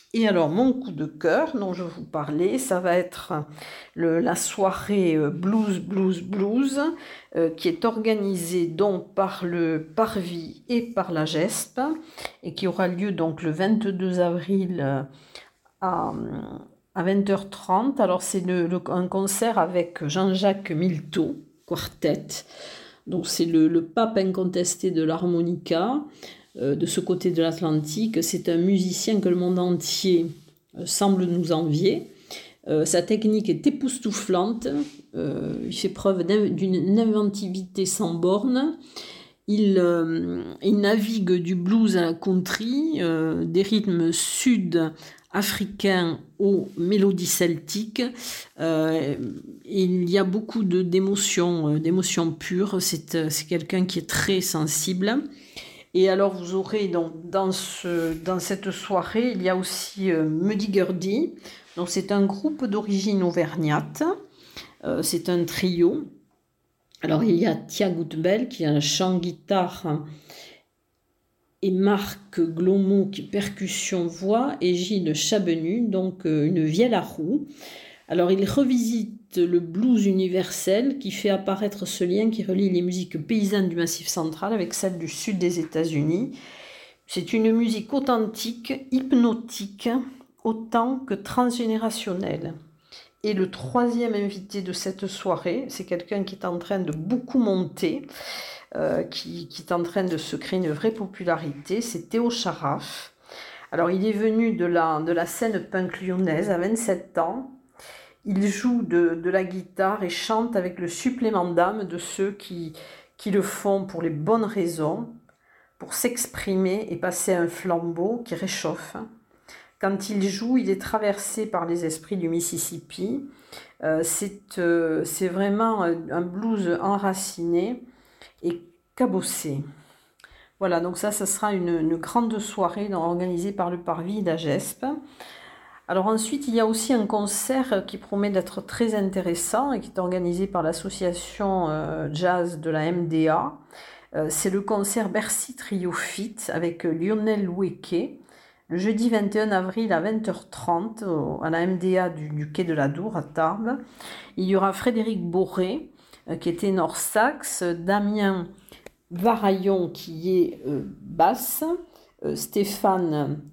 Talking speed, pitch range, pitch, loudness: 145 wpm, 170-215 Hz, 190 Hz, -25 LUFS